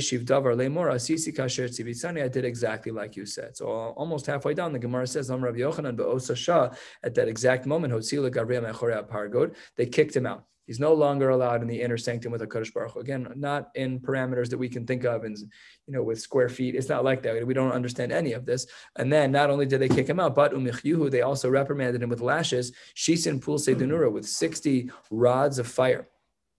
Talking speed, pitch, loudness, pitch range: 180 wpm, 130 Hz, -27 LUFS, 120-140 Hz